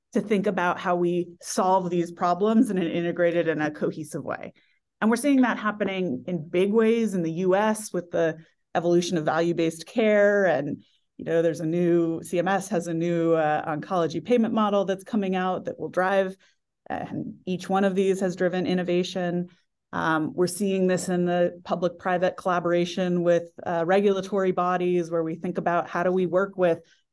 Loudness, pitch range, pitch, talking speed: -25 LUFS, 170-195 Hz, 180 Hz, 180 wpm